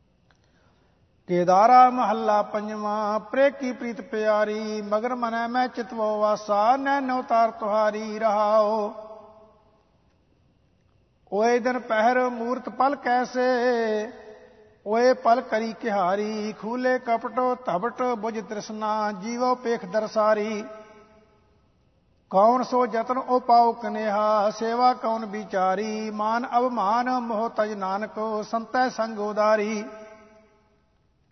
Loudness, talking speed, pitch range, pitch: -24 LUFS, 95 wpm, 215-245 Hz, 220 Hz